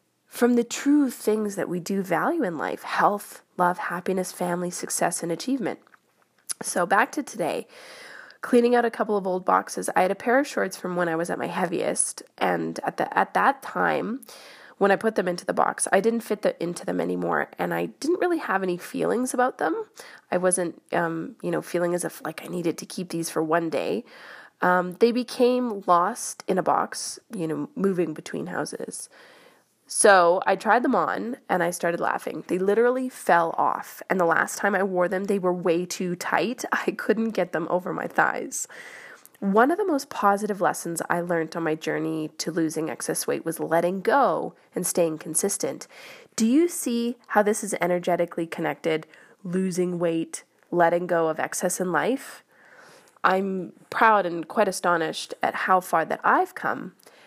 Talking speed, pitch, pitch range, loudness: 185 wpm, 185 Hz, 170-230 Hz, -25 LUFS